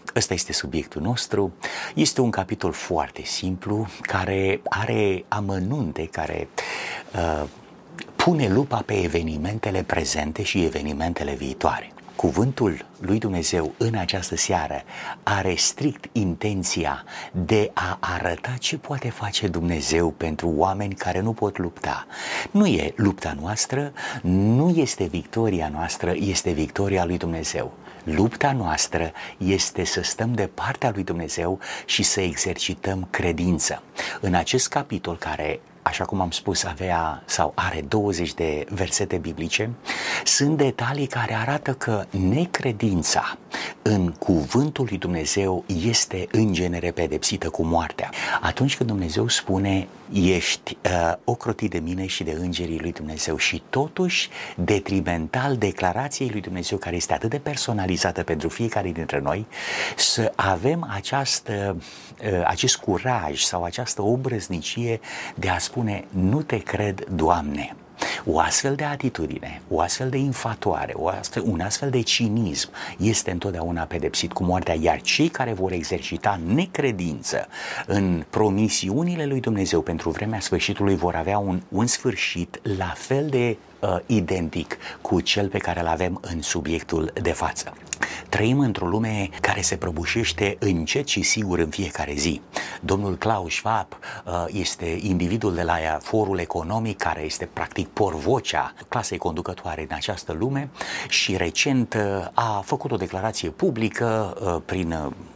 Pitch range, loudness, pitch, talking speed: 85-115 Hz, -24 LUFS, 95 Hz, 135 wpm